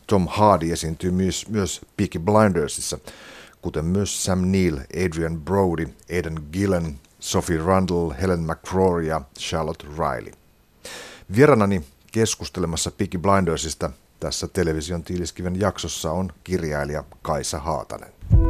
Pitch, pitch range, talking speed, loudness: 85 Hz, 80-95 Hz, 110 wpm, -23 LUFS